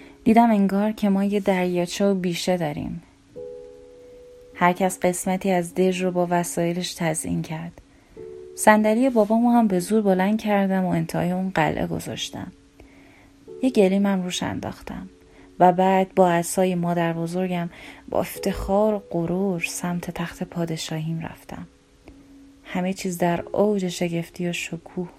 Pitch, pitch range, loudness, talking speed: 185 Hz, 175-210 Hz, -22 LUFS, 130 wpm